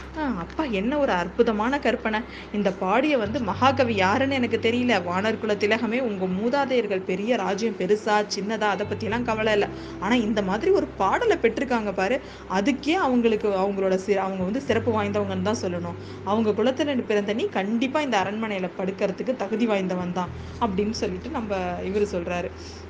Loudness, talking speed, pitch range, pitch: -24 LUFS, 150 wpm, 195-240 Hz, 215 Hz